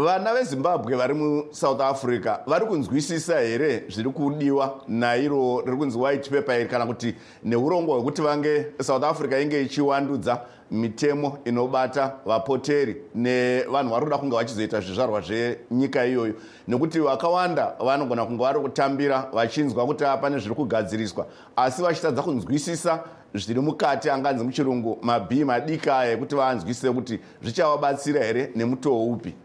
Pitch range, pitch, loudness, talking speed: 120-145 Hz, 135 Hz, -24 LUFS, 130 wpm